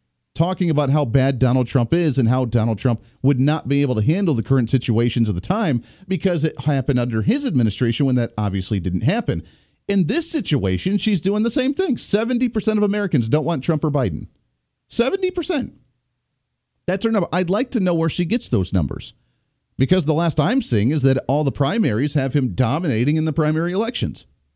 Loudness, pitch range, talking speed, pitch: -20 LUFS, 125-185 Hz, 195 wpm, 145 Hz